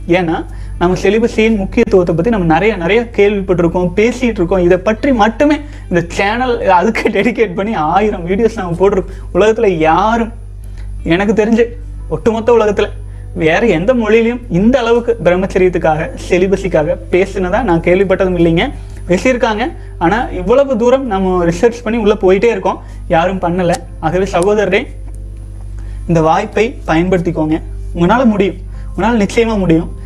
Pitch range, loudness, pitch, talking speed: 165-220 Hz, -13 LUFS, 190 Hz, 125 wpm